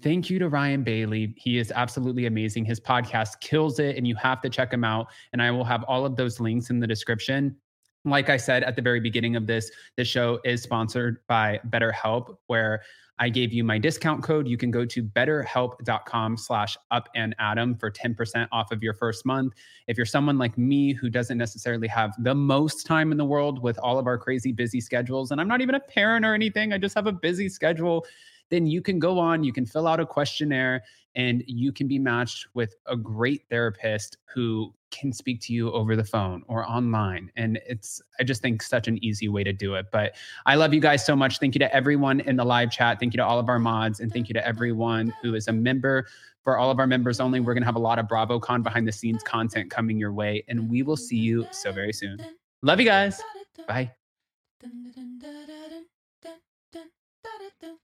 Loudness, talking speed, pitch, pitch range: -25 LUFS, 220 wpm, 125 Hz, 115-140 Hz